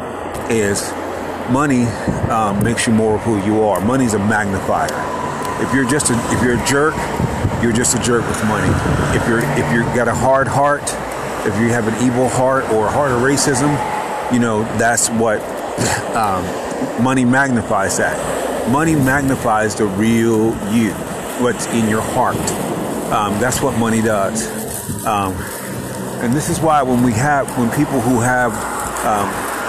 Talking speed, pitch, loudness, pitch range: 165 wpm, 120 Hz, -16 LUFS, 110-130 Hz